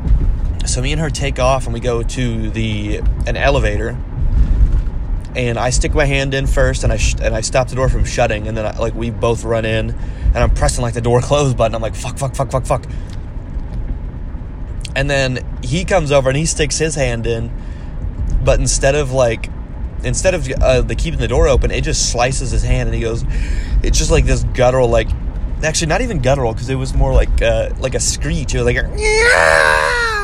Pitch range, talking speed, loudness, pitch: 110-135 Hz, 215 wpm, -16 LUFS, 120 Hz